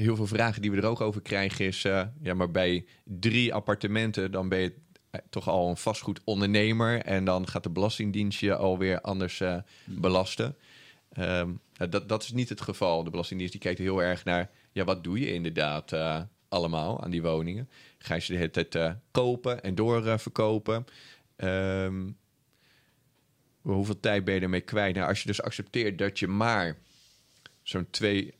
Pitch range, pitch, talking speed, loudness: 90-110 Hz, 100 Hz, 175 wpm, -29 LUFS